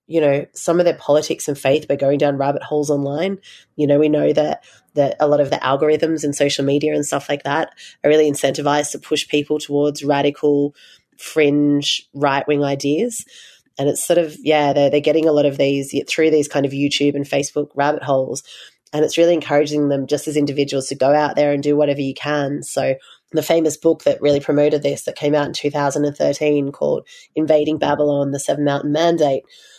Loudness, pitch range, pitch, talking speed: -18 LUFS, 140-150 Hz, 145 Hz, 205 wpm